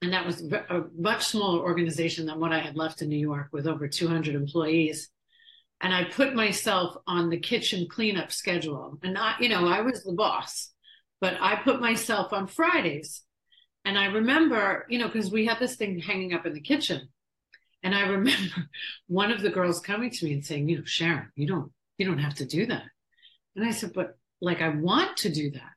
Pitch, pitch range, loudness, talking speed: 185 Hz, 165-220 Hz, -27 LUFS, 210 wpm